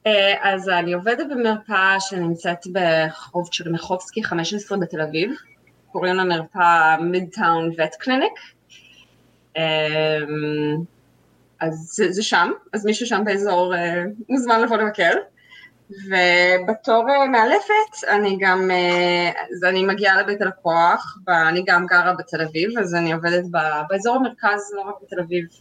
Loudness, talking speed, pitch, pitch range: -19 LUFS, 130 wpm, 180 Hz, 170-205 Hz